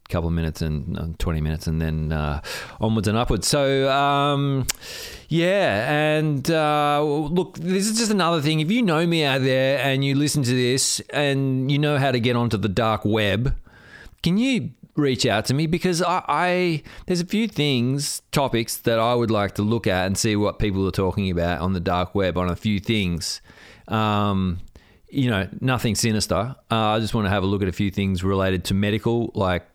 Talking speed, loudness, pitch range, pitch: 205 wpm, -22 LUFS, 100-145 Hz, 115 Hz